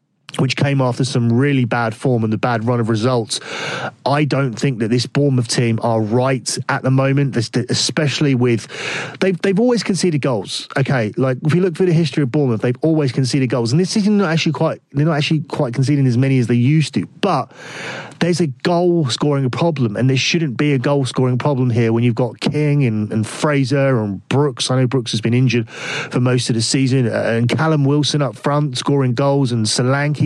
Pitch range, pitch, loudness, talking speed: 125-150 Hz, 135 Hz, -17 LUFS, 215 wpm